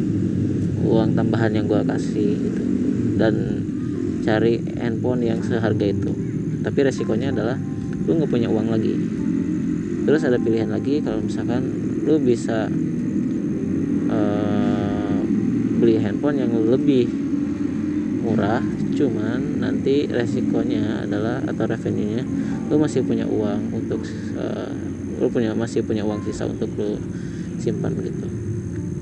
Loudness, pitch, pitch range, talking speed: -22 LUFS, 115 Hz, 105-145 Hz, 120 wpm